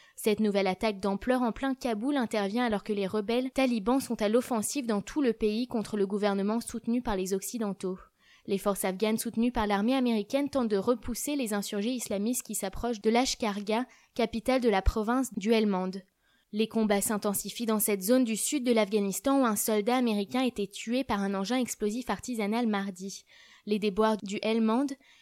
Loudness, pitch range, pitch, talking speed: -29 LUFS, 205-245 Hz, 220 Hz, 180 wpm